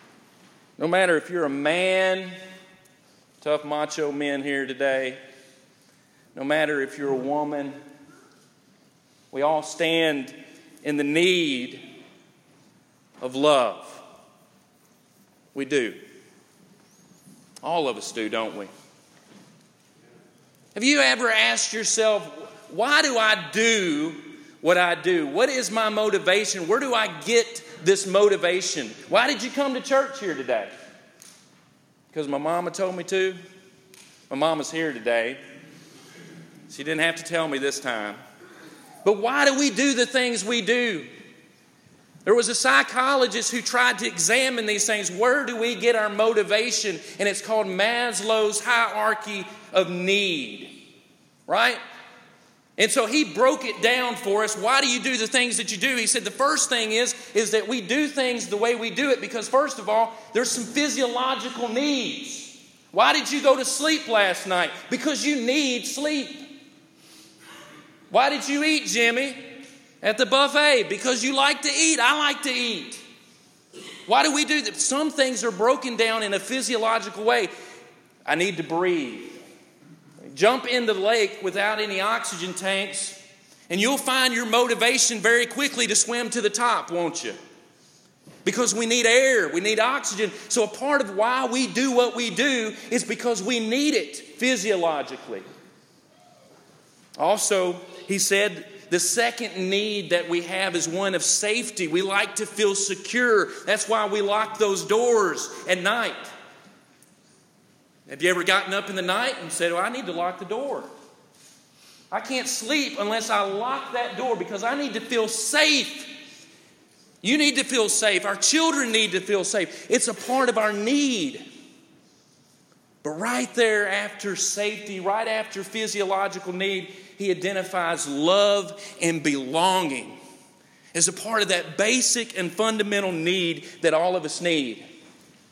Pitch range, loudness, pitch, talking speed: 185-250 Hz, -23 LUFS, 215 Hz, 155 wpm